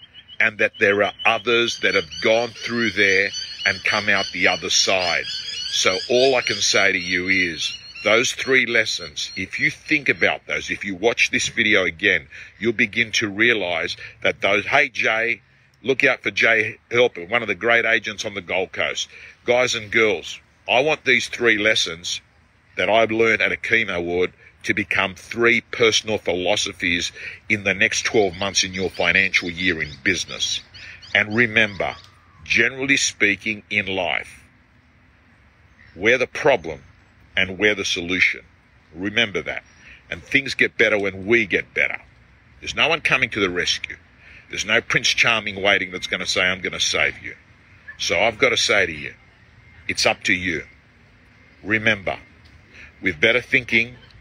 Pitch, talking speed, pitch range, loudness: 110 Hz, 165 wpm, 100-120 Hz, -19 LUFS